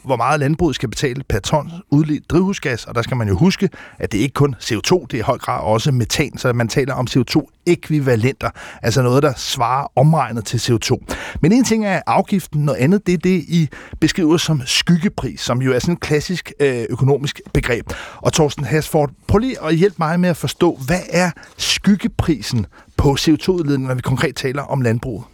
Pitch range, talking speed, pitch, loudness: 130-170 Hz, 195 wpm, 145 Hz, -18 LUFS